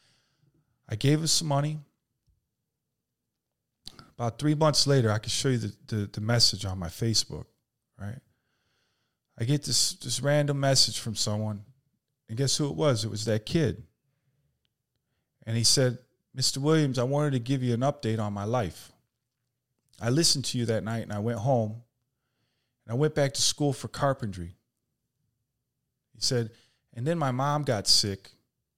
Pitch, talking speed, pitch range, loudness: 125 Hz, 165 wpm, 115-140 Hz, -27 LUFS